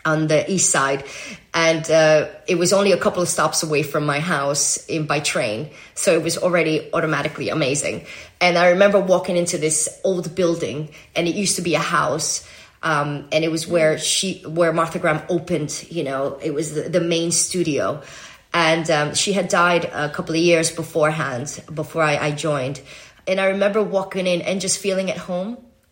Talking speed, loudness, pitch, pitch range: 190 wpm, -19 LUFS, 165 Hz, 155-180 Hz